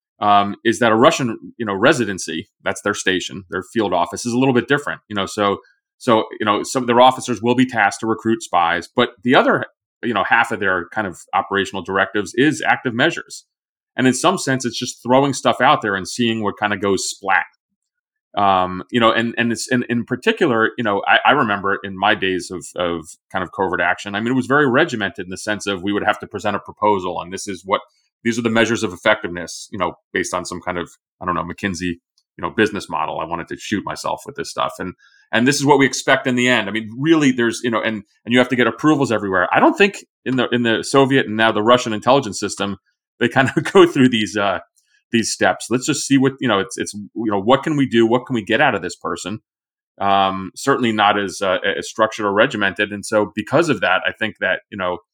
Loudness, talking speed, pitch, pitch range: -18 LUFS, 250 wpm, 110 Hz, 100-125 Hz